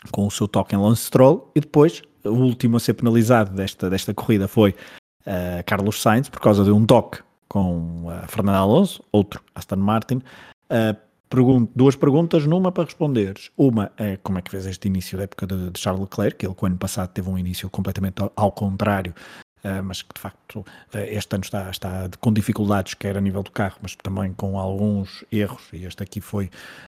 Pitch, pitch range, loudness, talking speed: 100 Hz, 95-115 Hz, -21 LUFS, 210 wpm